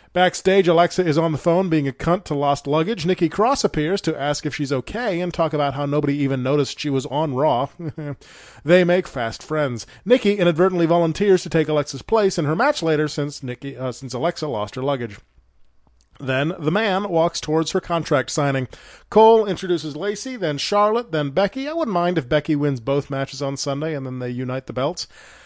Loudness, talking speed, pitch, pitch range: -20 LUFS, 200 wpm, 155 Hz, 140-175 Hz